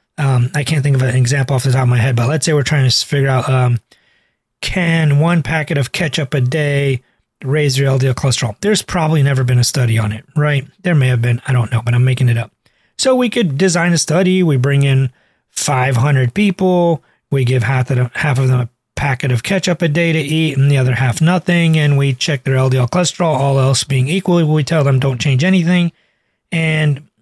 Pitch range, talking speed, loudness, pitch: 130-160 Hz, 225 wpm, -14 LUFS, 140 Hz